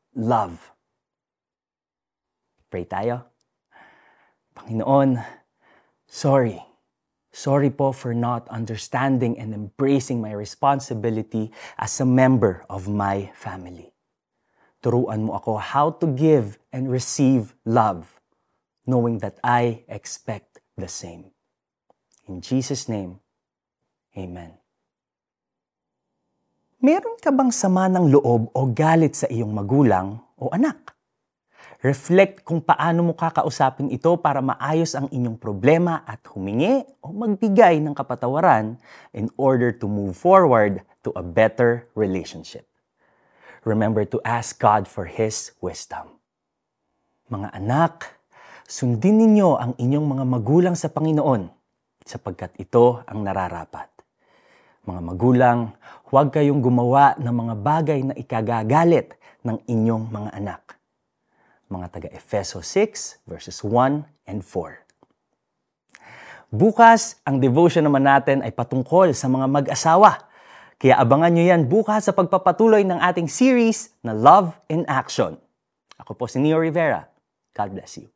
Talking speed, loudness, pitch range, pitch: 115 wpm, -20 LUFS, 110-155 Hz, 130 Hz